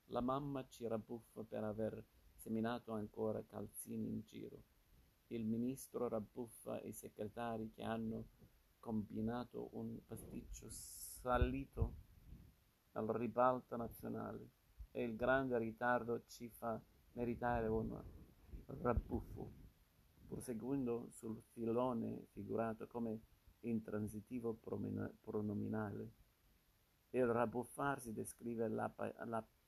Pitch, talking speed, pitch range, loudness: 115 Hz, 95 wpm, 110-120 Hz, -44 LUFS